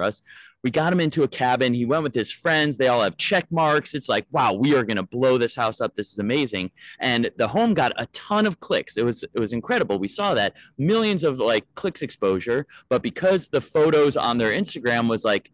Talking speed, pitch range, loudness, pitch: 235 wpm, 120-160 Hz, -22 LUFS, 130 Hz